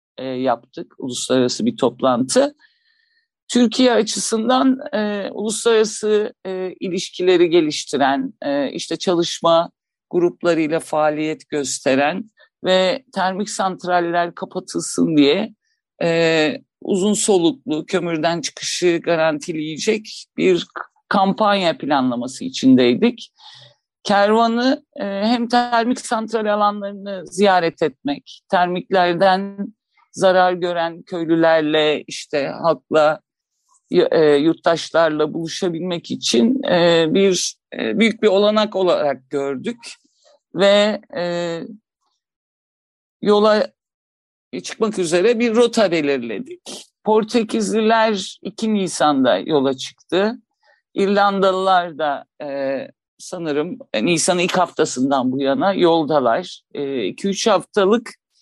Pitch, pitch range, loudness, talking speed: 195 Hz, 165-230 Hz, -18 LUFS, 80 wpm